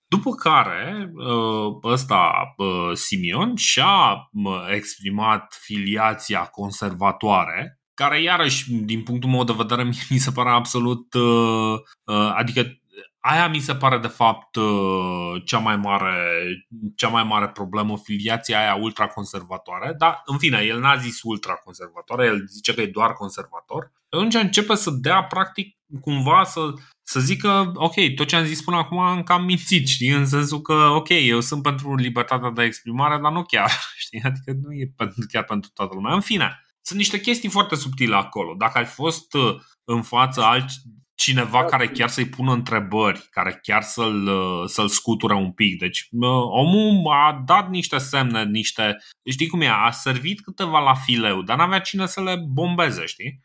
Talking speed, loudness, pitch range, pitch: 155 wpm, -20 LUFS, 110-155 Hz, 125 Hz